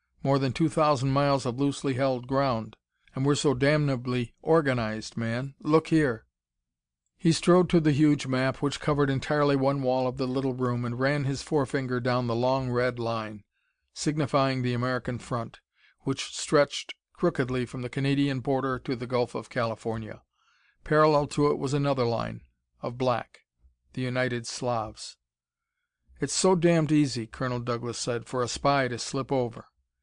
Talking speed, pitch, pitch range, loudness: 160 wpm, 130 Hz, 120-145 Hz, -27 LUFS